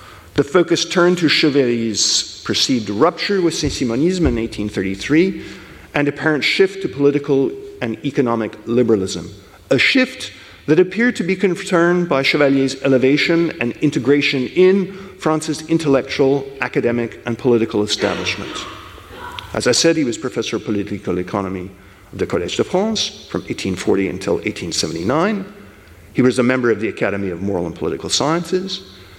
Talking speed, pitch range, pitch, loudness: 140 wpm, 110-170 Hz, 135 Hz, -17 LUFS